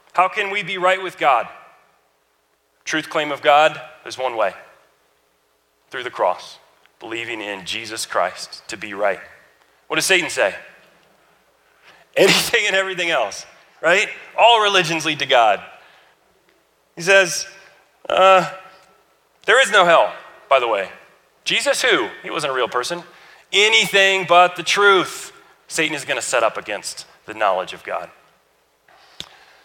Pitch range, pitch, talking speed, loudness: 125-190 Hz, 175 Hz, 140 wpm, -17 LUFS